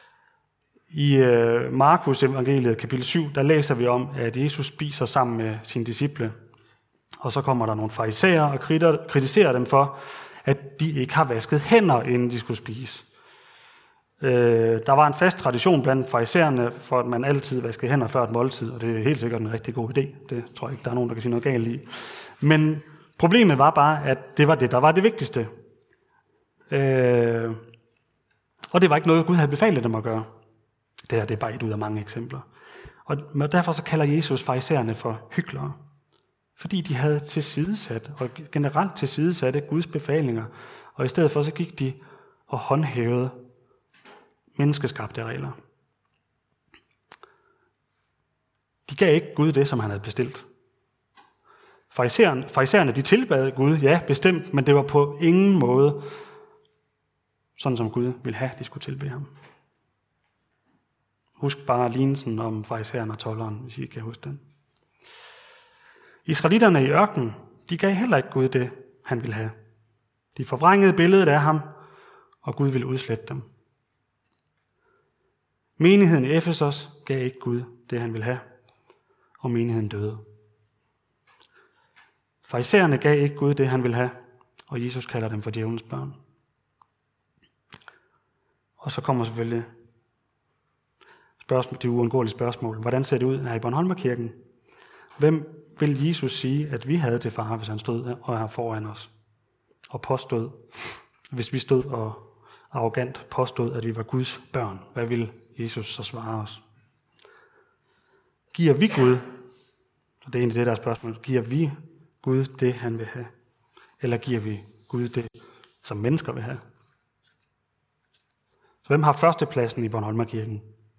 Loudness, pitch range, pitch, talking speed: -23 LUFS, 115-150 Hz, 130 Hz, 155 wpm